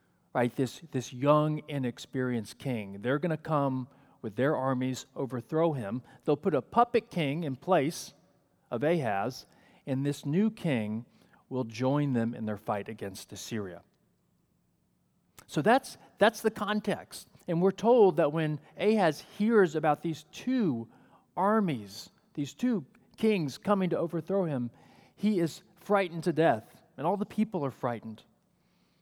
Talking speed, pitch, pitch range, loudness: 145 wpm, 150 Hz, 125-190 Hz, -30 LUFS